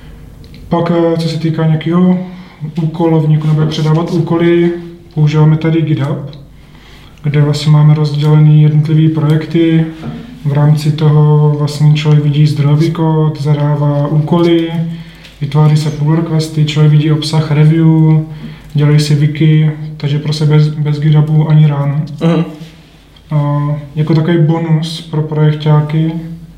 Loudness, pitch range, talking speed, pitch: -11 LUFS, 150-160 Hz, 115 wpm, 155 Hz